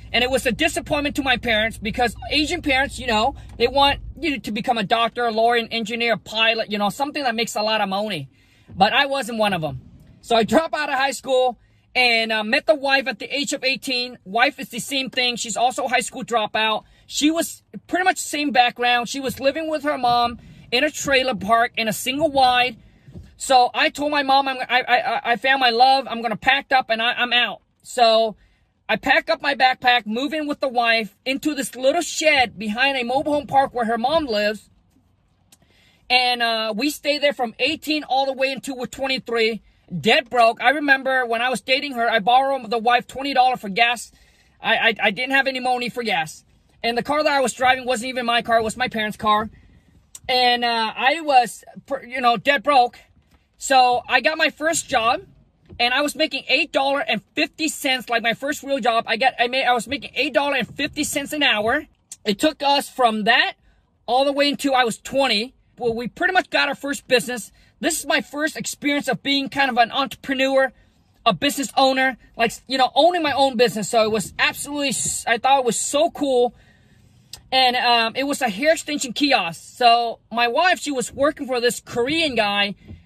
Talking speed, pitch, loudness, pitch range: 210 wpm, 255 Hz, -20 LUFS, 230-275 Hz